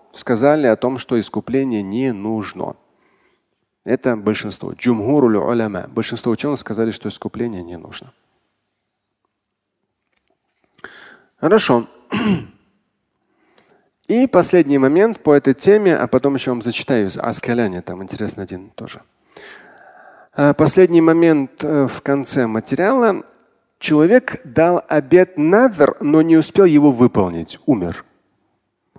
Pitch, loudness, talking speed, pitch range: 130 Hz, -16 LUFS, 100 wpm, 110-160 Hz